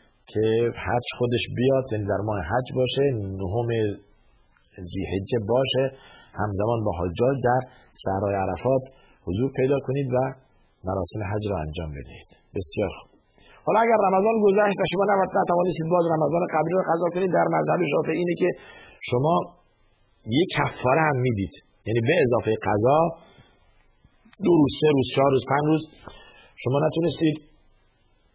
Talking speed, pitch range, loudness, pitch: 140 wpm, 105-160 Hz, -24 LUFS, 130 Hz